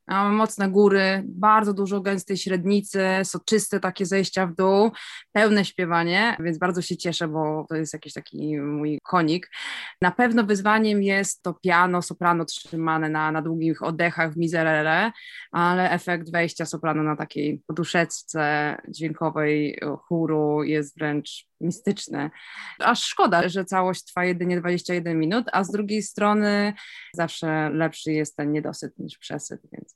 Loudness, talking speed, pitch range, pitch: -23 LUFS, 140 wpm, 160-195 Hz, 175 Hz